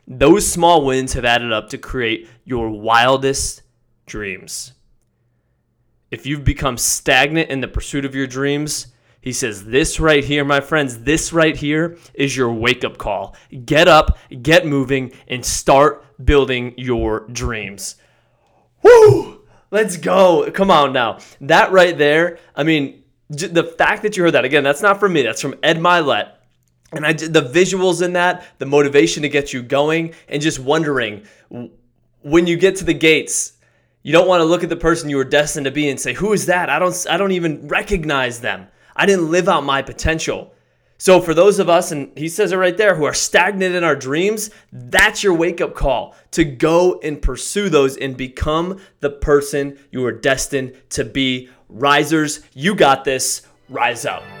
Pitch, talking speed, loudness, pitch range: 145 Hz, 180 wpm, -16 LUFS, 130-170 Hz